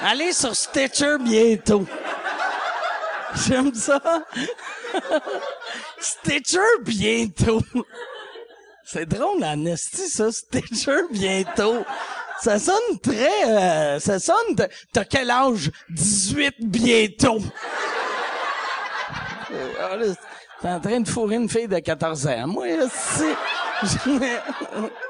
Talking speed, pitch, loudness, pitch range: 95 wpm, 230 Hz, -22 LUFS, 195-285 Hz